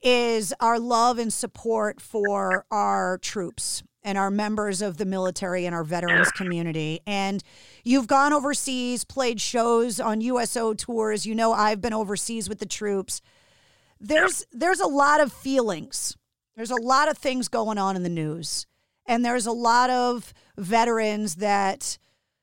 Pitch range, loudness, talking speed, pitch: 195-245 Hz, -24 LUFS, 155 wpm, 220 Hz